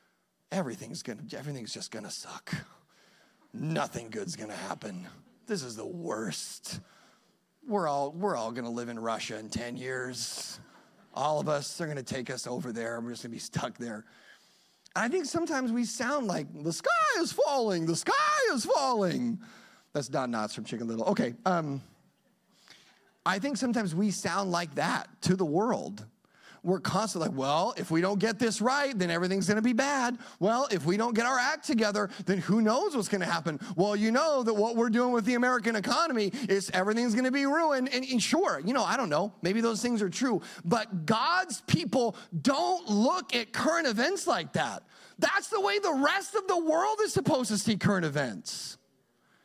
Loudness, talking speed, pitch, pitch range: -30 LUFS, 185 wpm, 215 Hz, 170-255 Hz